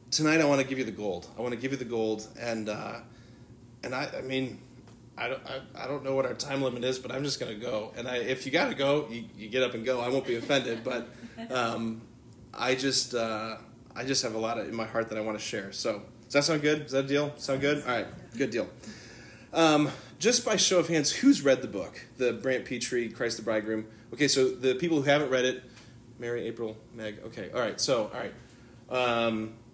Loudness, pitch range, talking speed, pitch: -29 LUFS, 115-135 Hz, 250 wpm, 125 Hz